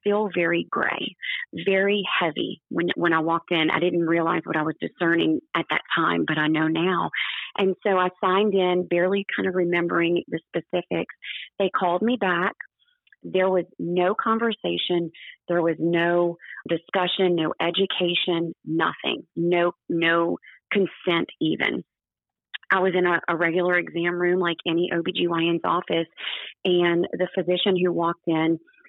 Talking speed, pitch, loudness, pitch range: 150 wpm, 175 Hz, -23 LUFS, 170-185 Hz